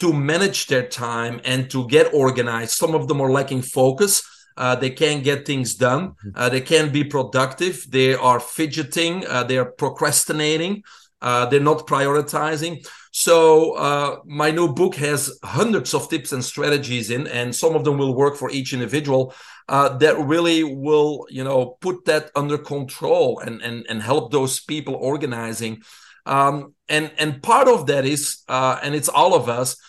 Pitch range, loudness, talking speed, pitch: 130-155 Hz, -19 LUFS, 175 wpm, 145 Hz